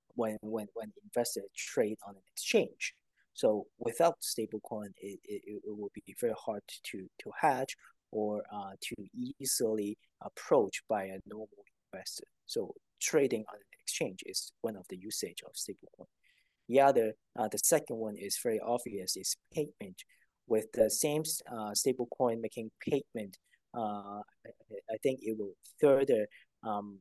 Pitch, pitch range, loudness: 110 Hz, 105-135 Hz, -34 LUFS